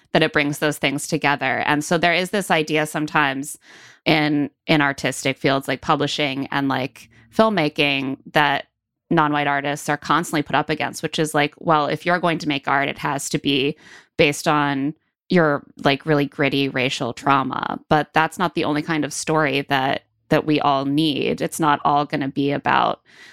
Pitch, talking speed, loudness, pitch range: 150 Hz, 185 wpm, -20 LUFS, 140-155 Hz